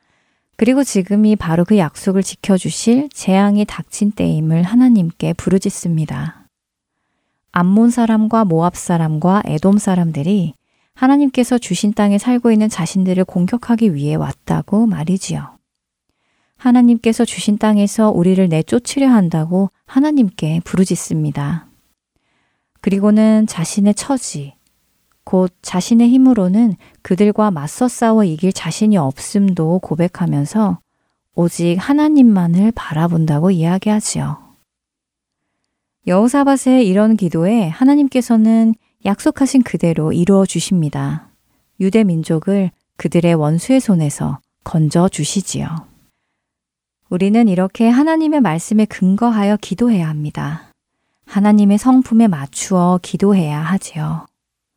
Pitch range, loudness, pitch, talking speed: 170-225 Hz, -15 LUFS, 195 Hz, 280 characters per minute